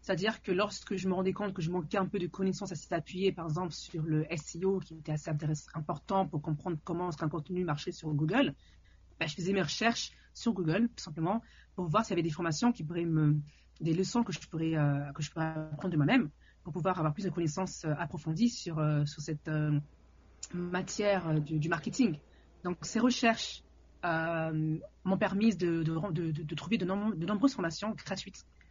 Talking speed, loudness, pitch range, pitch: 200 wpm, -33 LUFS, 155-190 Hz, 170 Hz